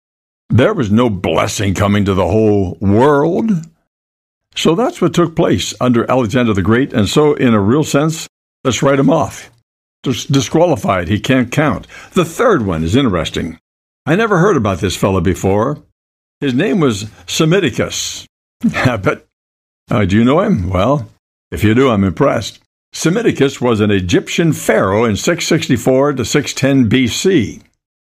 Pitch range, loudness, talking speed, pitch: 100-140 Hz, -14 LUFS, 150 wpm, 115 Hz